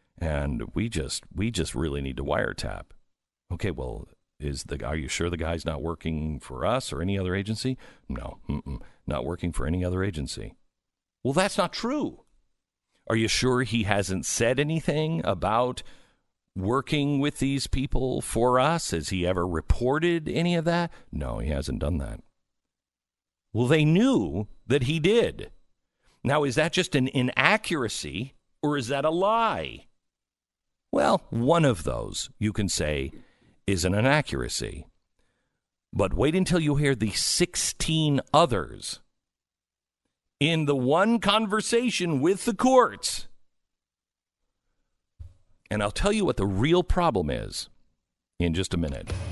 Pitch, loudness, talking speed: 120 Hz, -26 LUFS, 145 wpm